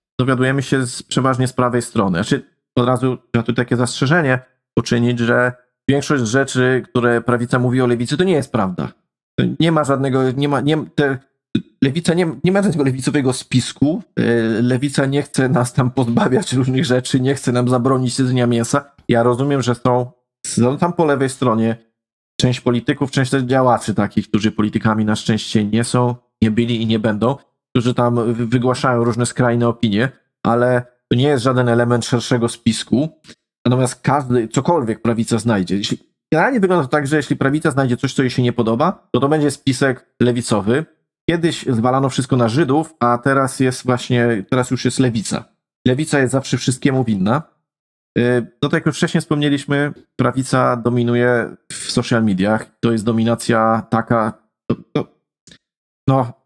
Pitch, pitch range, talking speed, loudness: 125 Hz, 120-135 Hz, 170 wpm, -17 LUFS